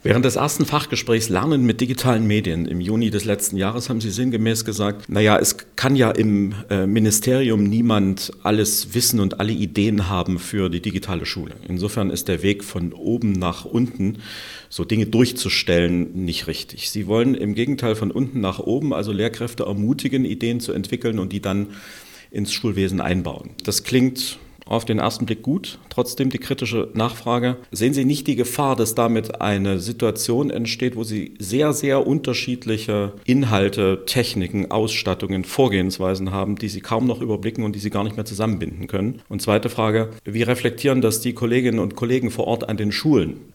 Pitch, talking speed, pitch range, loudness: 110 Hz, 175 wpm, 100-120 Hz, -21 LUFS